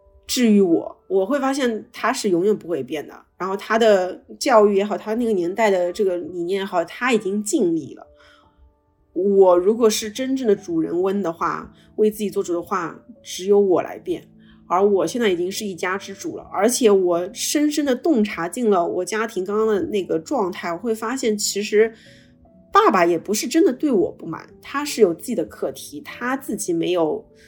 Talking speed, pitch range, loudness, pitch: 275 characters per minute, 190-250 Hz, -20 LUFS, 210 Hz